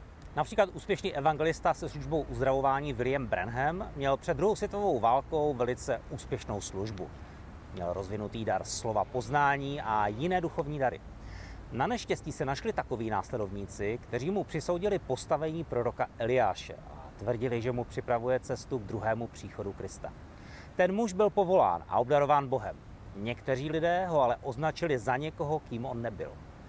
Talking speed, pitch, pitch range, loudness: 145 wpm, 130 Hz, 110-160 Hz, -31 LUFS